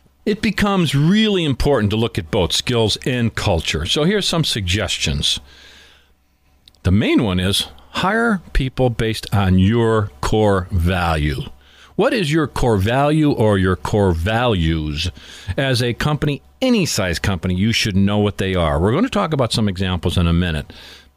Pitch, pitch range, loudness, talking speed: 105 Hz, 90-140 Hz, -18 LUFS, 160 wpm